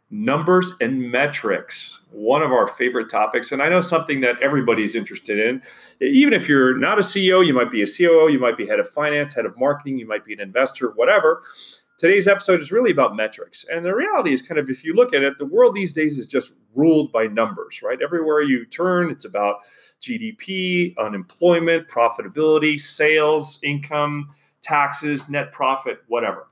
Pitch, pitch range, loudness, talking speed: 155 Hz, 135-190 Hz, -19 LUFS, 190 wpm